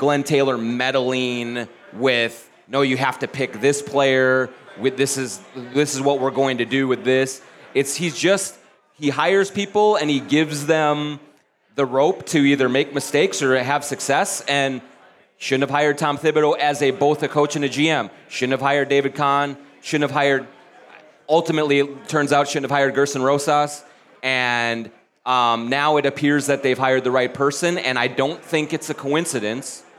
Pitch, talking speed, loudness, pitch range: 140 Hz, 180 wpm, -20 LUFS, 130-145 Hz